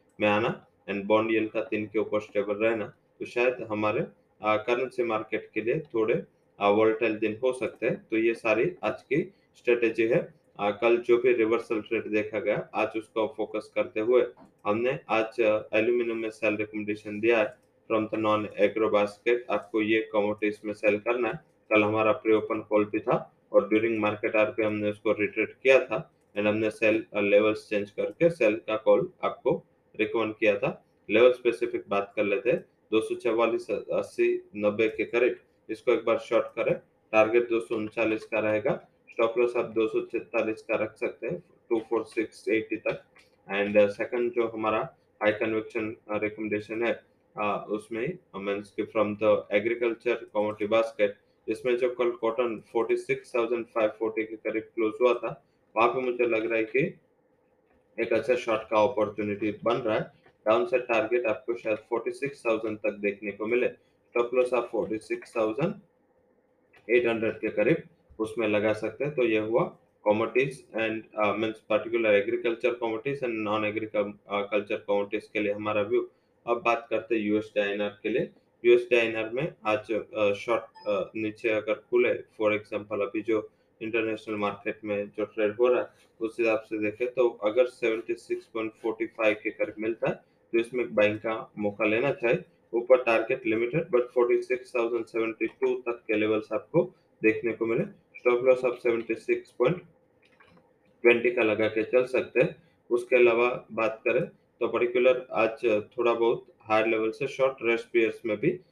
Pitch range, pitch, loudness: 105-120 Hz, 110 Hz, -27 LUFS